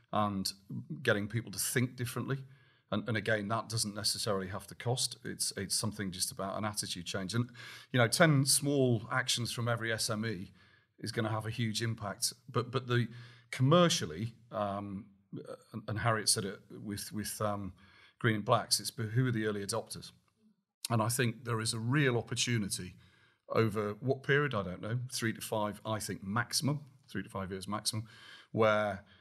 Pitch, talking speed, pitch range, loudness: 110 Hz, 180 wpm, 105-120 Hz, -33 LUFS